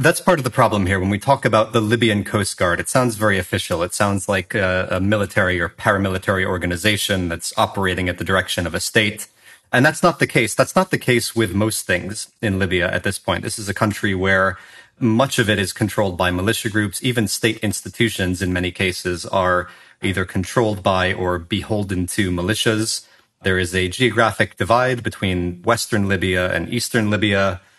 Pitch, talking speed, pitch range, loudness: 105 Hz, 195 wpm, 95-115 Hz, -19 LUFS